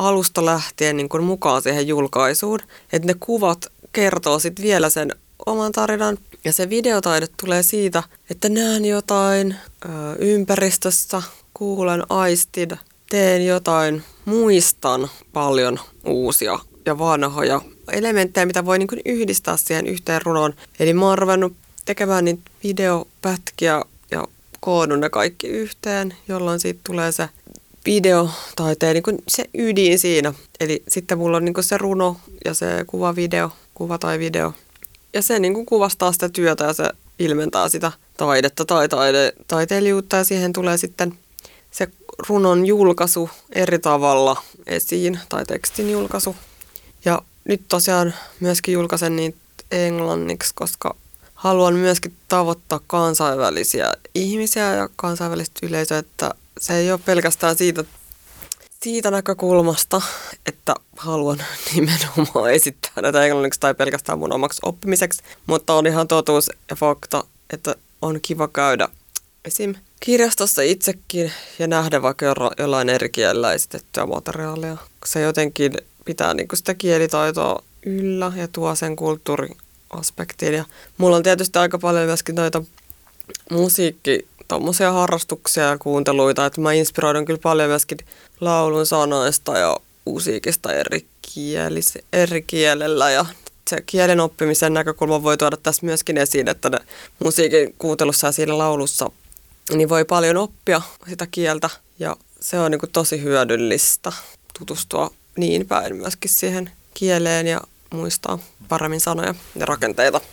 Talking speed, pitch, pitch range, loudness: 130 wpm, 170 Hz, 155-185 Hz, -19 LUFS